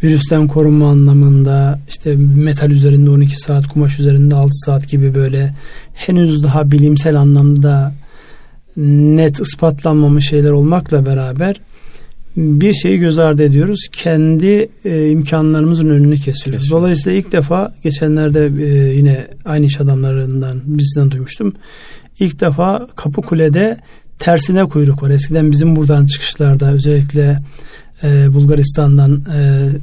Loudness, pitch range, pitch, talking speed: -12 LUFS, 140-160 Hz, 145 Hz, 115 wpm